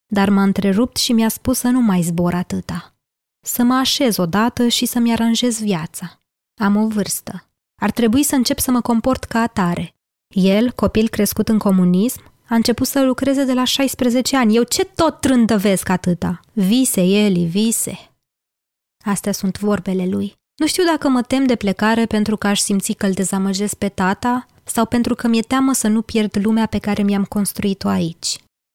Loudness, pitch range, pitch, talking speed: -17 LUFS, 195-245 Hz, 215 Hz, 180 wpm